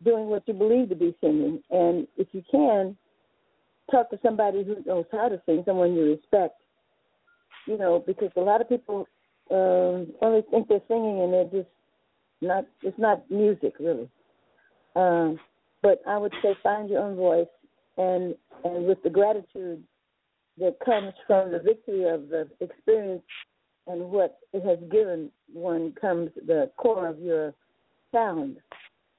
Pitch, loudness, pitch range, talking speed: 195 Hz, -25 LUFS, 175-215 Hz, 155 wpm